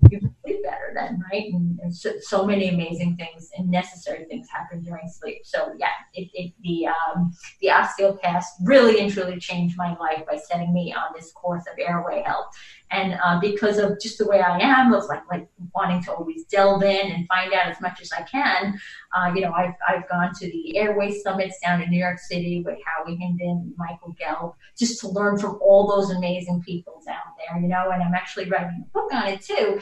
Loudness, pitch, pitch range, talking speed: -23 LUFS, 180 Hz, 175-200 Hz, 215 wpm